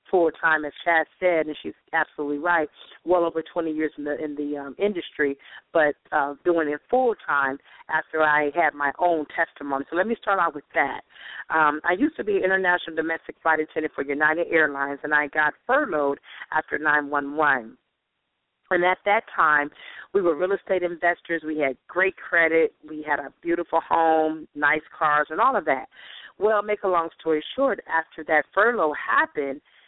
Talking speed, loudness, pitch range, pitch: 185 wpm, -23 LUFS, 150-175 Hz, 160 Hz